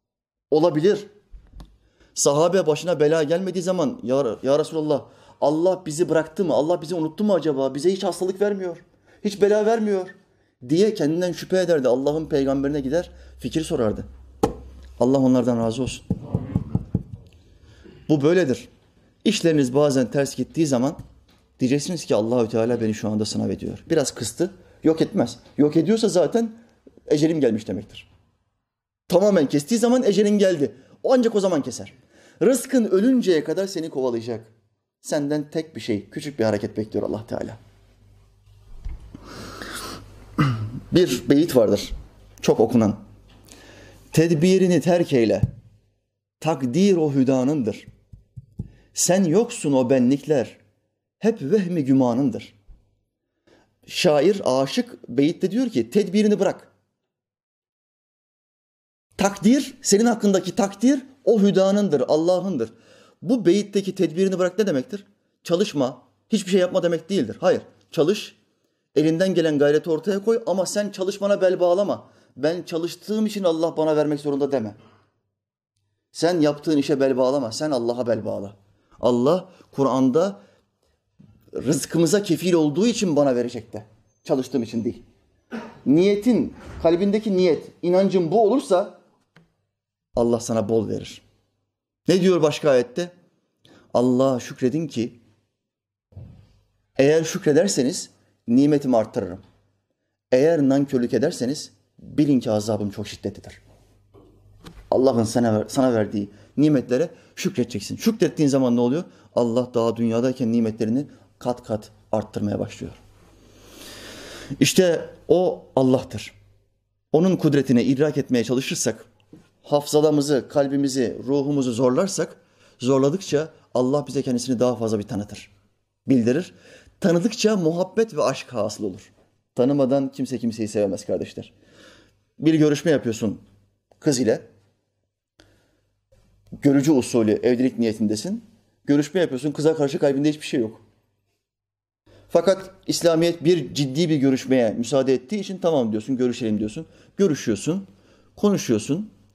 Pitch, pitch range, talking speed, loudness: 135 Hz, 110-175 Hz, 115 wpm, -21 LUFS